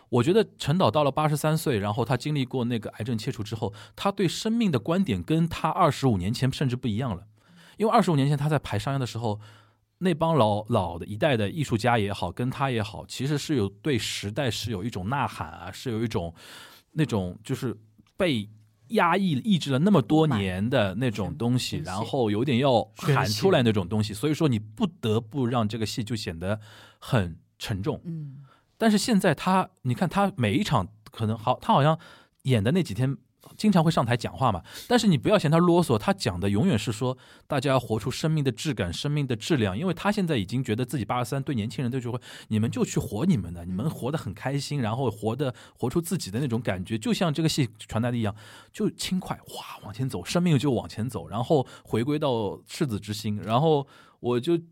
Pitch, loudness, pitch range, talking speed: 125 Hz, -26 LUFS, 110-155 Hz, 320 characters per minute